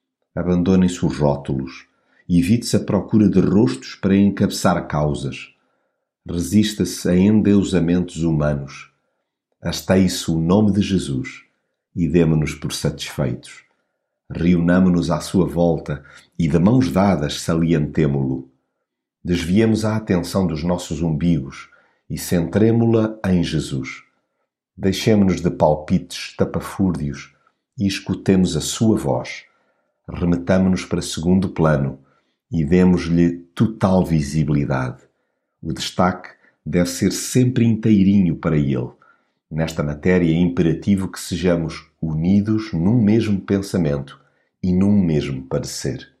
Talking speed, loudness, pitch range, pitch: 110 wpm, -19 LUFS, 80-95 Hz, 90 Hz